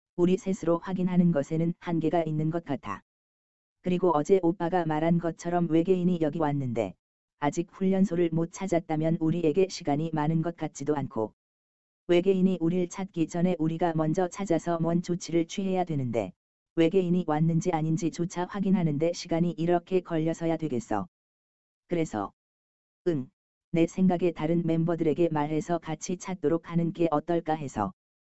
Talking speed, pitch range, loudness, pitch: 330 characters per minute, 155-175 Hz, -28 LUFS, 165 Hz